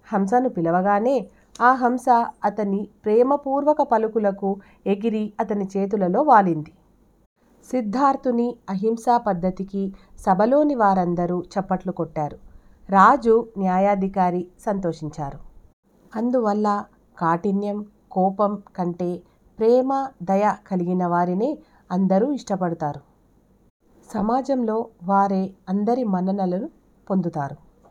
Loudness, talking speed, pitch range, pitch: -22 LUFS, 75 wpm, 185-230 Hz, 200 Hz